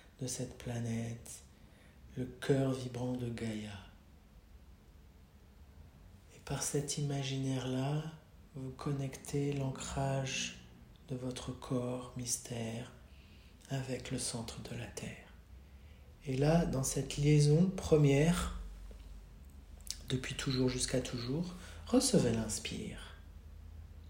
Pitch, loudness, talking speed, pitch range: 125 Hz, -36 LUFS, 90 wpm, 80-135 Hz